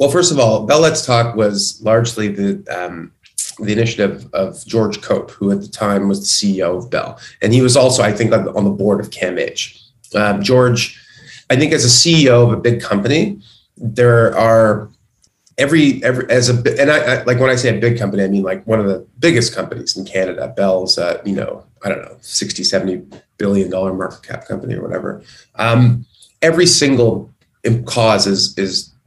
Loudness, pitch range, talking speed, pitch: -14 LUFS, 100-120 Hz, 195 wpm, 110 Hz